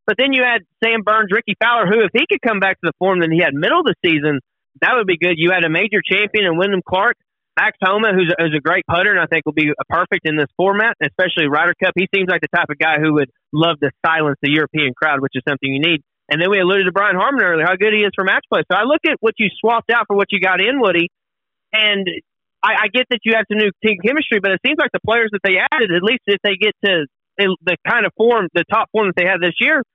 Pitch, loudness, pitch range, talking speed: 190 Hz, -15 LUFS, 165-215 Hz, 290 wpm